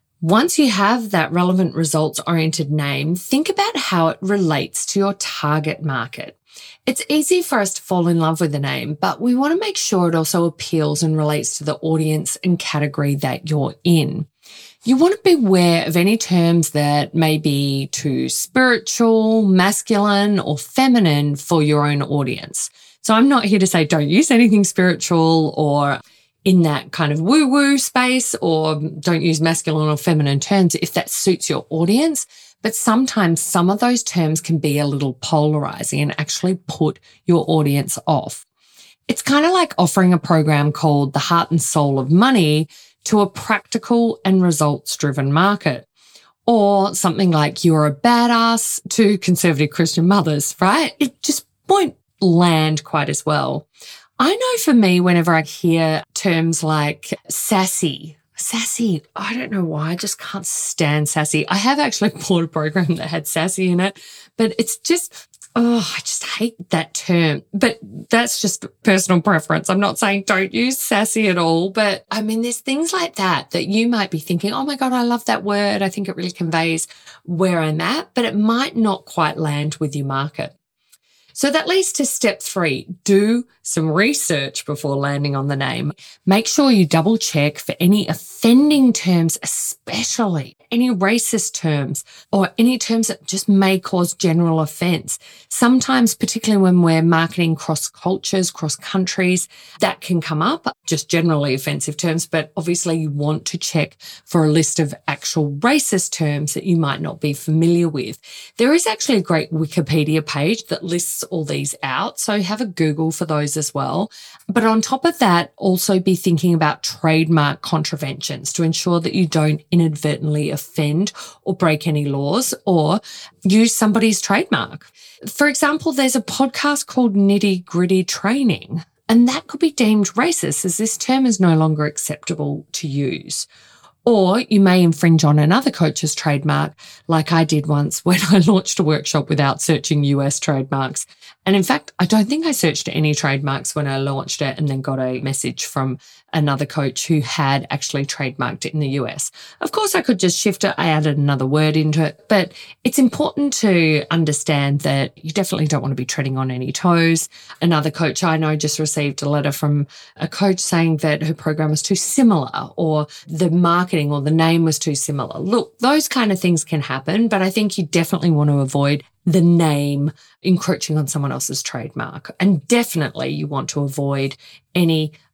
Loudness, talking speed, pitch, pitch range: -18 LUFS, 180 wpm, 170 Hz, 150-205 Hz